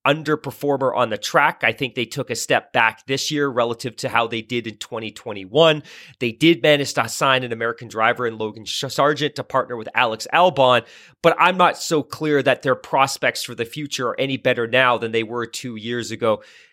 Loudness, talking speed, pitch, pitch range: -20 LUFS, 205 wpm, 125 Hz, 115-140 Hz